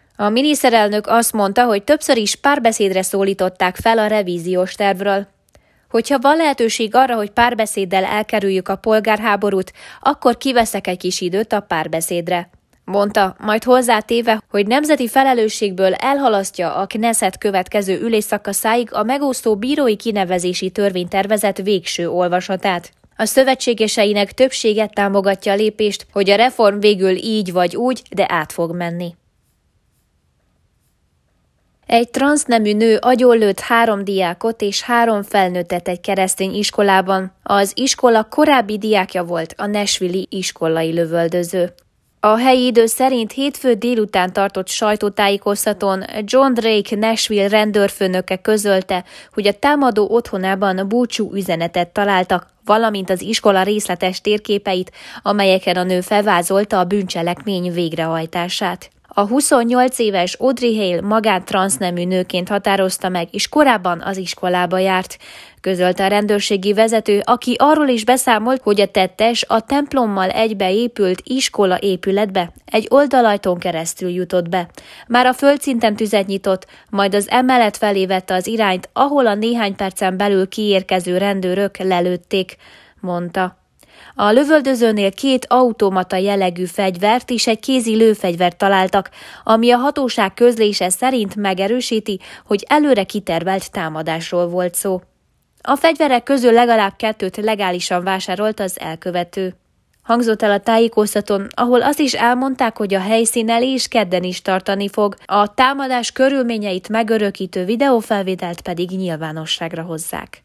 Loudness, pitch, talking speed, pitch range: -16 LUFS, 205 Hz, 125 wpm, 185-230 Hz